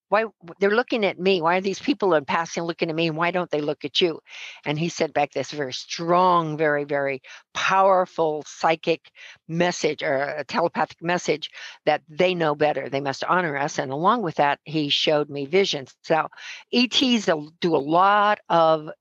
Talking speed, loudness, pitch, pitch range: 185 wpm, -23 LUFS, 165 Hz, 150-185 Hz